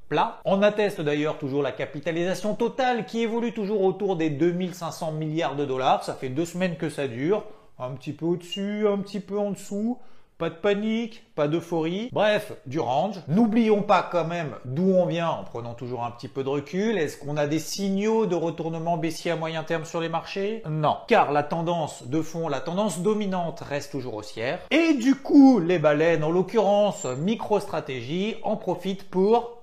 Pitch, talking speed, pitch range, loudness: 175 Hz, 190 wpm, 155-210 Hz, -25 LUFS